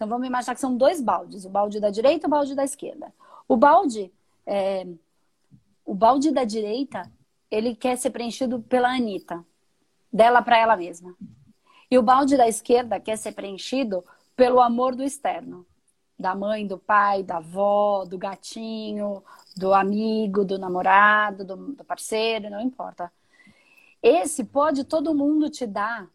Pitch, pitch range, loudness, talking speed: 220 Hz, 195-255 Hz, -22 LUFS, 155 wpm